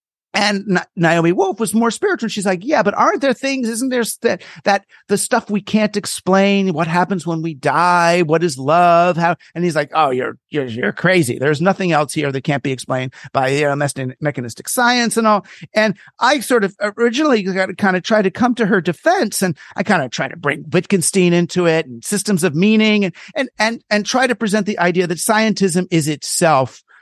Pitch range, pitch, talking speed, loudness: 165-215 Hz, 190 Hz, 215 wpm, -16 LUFS